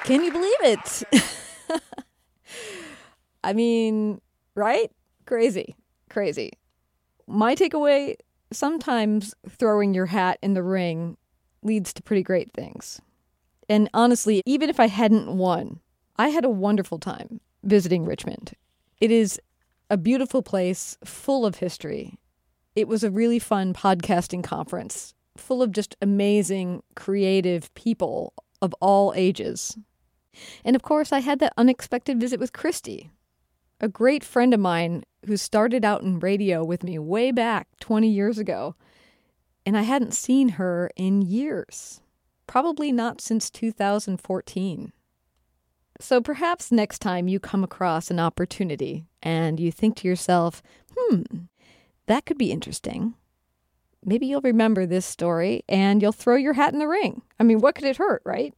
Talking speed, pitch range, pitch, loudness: 140 wpm, 180-245 Hz, 210 Hz, -23 LUFS